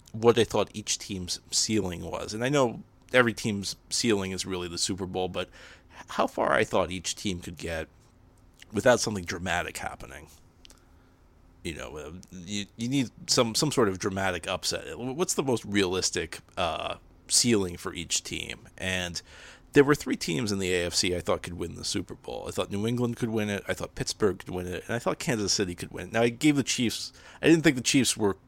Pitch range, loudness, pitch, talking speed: 90-115 Hz, -28 LUFS, 95 Hz, 205 wpm